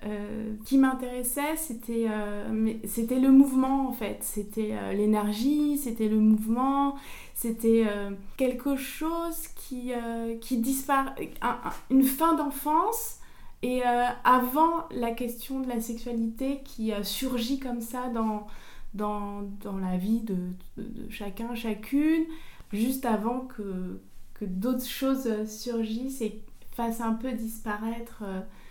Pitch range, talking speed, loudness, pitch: 215-265 Hz, 140 wpm, -28 LUFS, 235 Hz